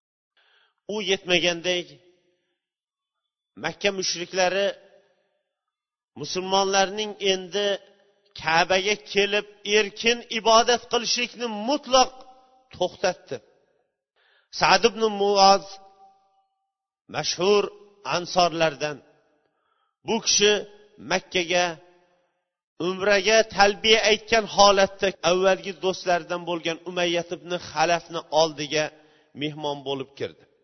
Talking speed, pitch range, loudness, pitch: 70 wpm, 175-210 Hz, -23 LUFS, 195 Hz